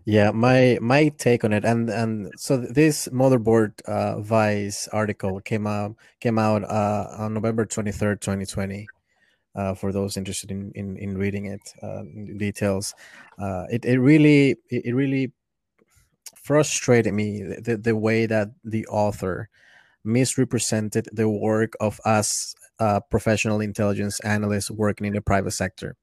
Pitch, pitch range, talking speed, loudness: 105 Hz, 100-115 Hz, 145 wpm, -23 LUFS